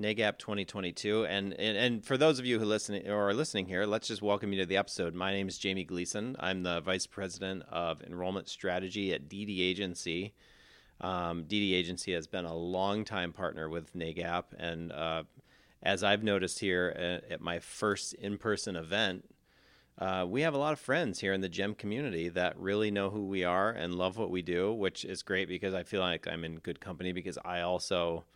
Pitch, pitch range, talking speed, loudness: 95 Hz, 90-100 Hz, 205 wpm, -34 LUFS